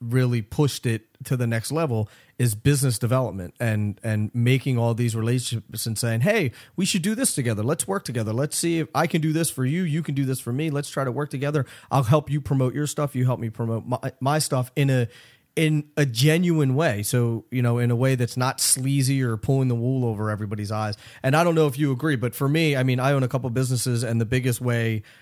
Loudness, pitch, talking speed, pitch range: -23 LUFS, 130 Hz, 250 wpm, 120-145 Hz